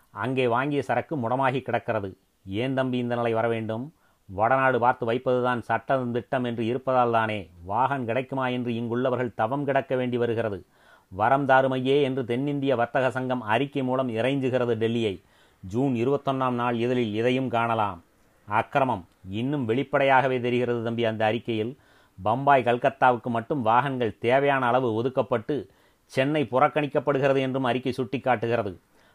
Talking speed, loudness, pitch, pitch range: 120 wpm, -25 LUFS, 125 Hz, 115-130 Hz